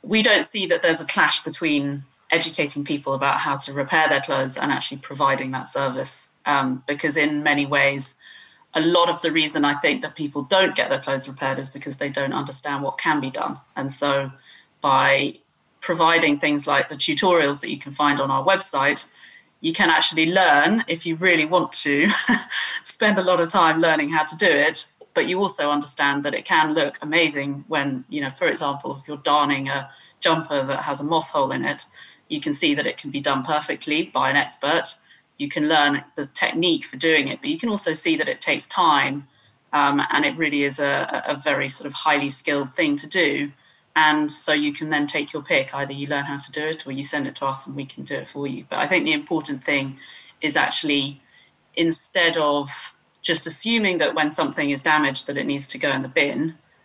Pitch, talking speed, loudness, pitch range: 150 Hz, 215 wpm, -21 LUFS, 140-165 Hz